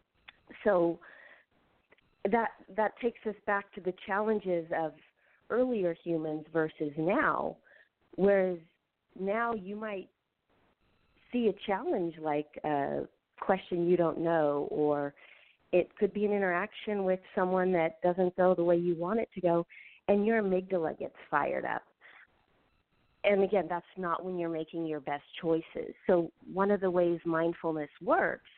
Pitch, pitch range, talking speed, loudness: 180 Hz, 165-200 Hz, 145 wpm, -31 LUFS